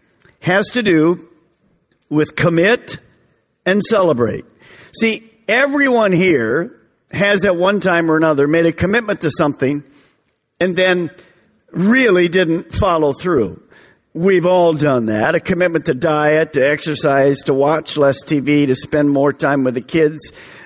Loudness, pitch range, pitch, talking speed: -15 LUFS, 145-185 Hz, 165 Hz, 140 wpm